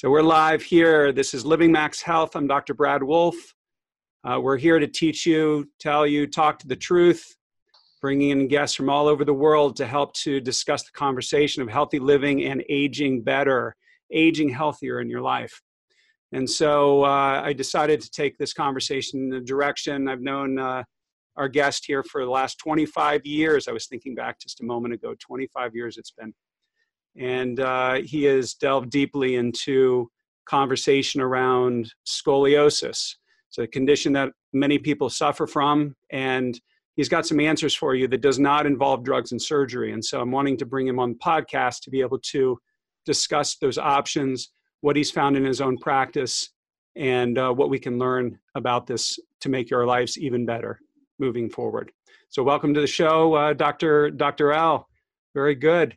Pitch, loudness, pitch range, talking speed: 140 Hz, -22 LUFS, 130-150 Hz, 180 wpm